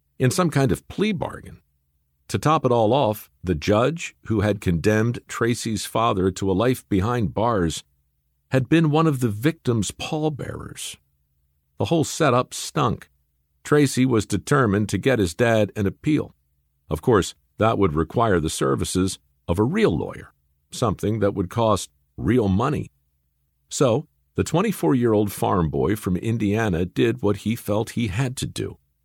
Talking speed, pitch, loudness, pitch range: 160 wpm, 105 Hz, -22 LUFS, 80-120 Hz